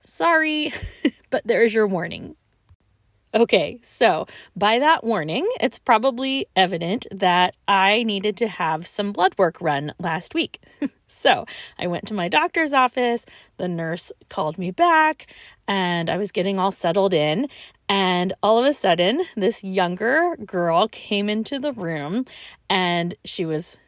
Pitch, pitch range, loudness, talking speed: 195 Hz, 175-245 Hz, -21 LUFS, 145 wpm